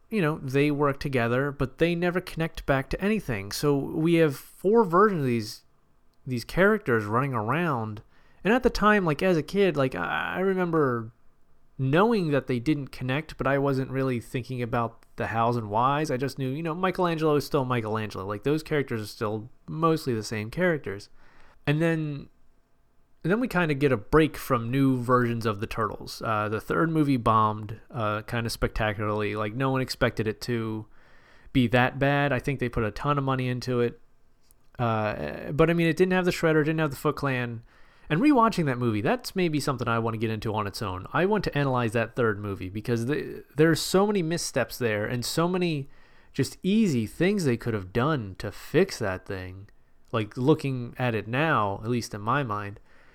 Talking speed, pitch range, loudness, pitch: 200 wpm, 115-155 Hz, -26 LUFS, 130 Hz